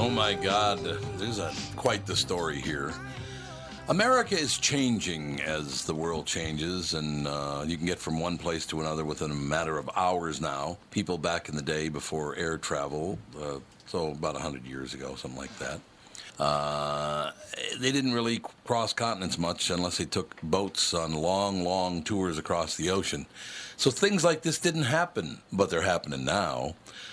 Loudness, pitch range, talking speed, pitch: -29 LUFS, 75-105 Hz, 175 wpm, 85 Hz